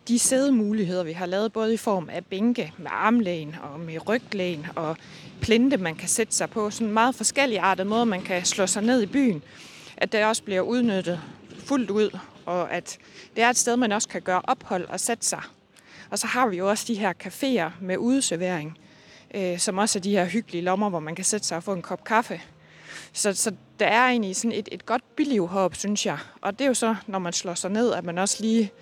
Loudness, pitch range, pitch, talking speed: -25 LUFS, 180-230 Hz, 205 Hz, 230 wpm